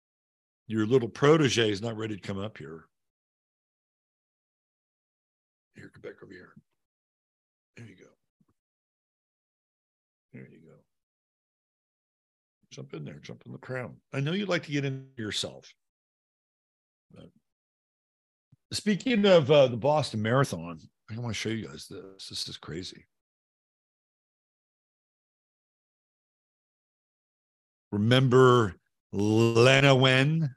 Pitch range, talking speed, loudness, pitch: 105-135 Hz, 110 wpm, -25 LUFS, 120 Hz